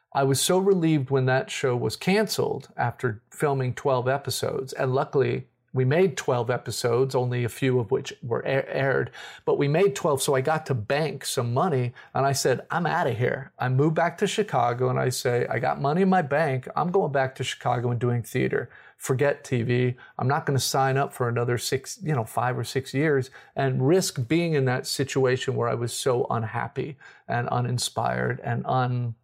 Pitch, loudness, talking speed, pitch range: 130 Hz, -25 LUFS, 205 wpm, 125-145 Hz